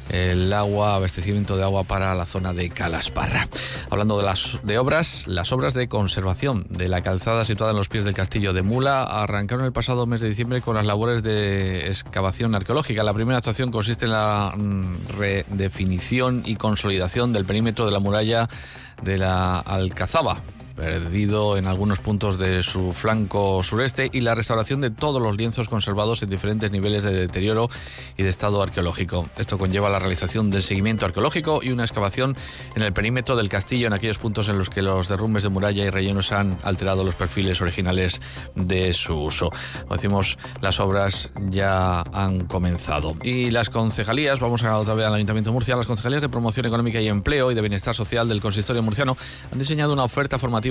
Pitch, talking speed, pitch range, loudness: 105 Hz, 185 wpm, 95-115 Hz, -22 LUFS